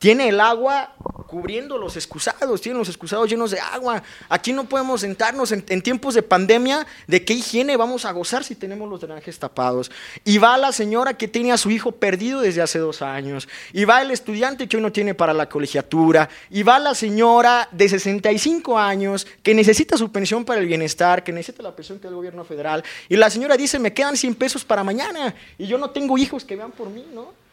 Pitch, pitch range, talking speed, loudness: 220 Hz, 185-245 Hz, 215 wpm, -19 LUFS